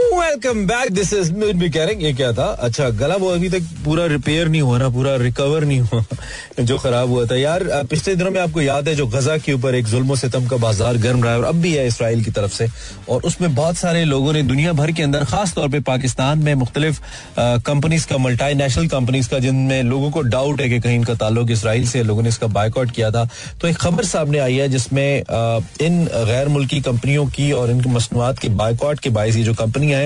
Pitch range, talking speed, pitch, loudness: 120-155 Hz, 215 wpm, 135 Hz, -18 LUFS